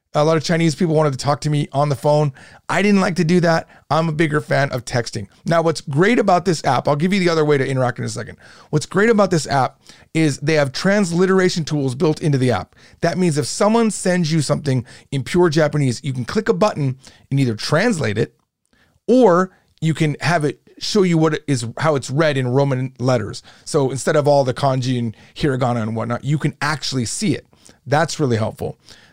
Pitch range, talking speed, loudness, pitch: 130-170 Hz, 225 wpm, -18 LUFS, 150 Hz